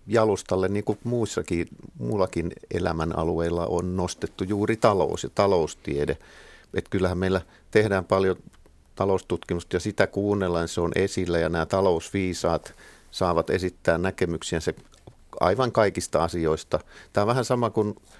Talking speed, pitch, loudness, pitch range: 130 wpm, 95 Hz, -25 LUFS, 85-105 Hz